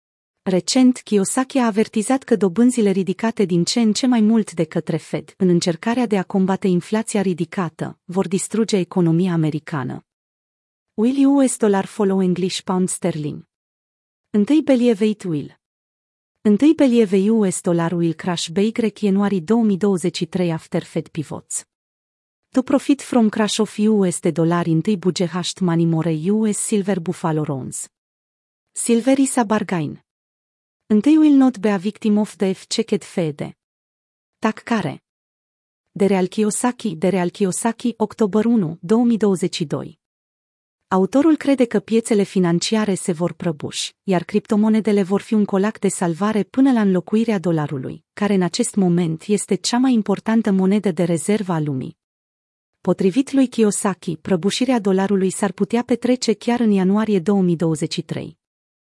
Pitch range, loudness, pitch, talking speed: 175-220 Hz, -19 LUFS, 195 Hz, 140 wpm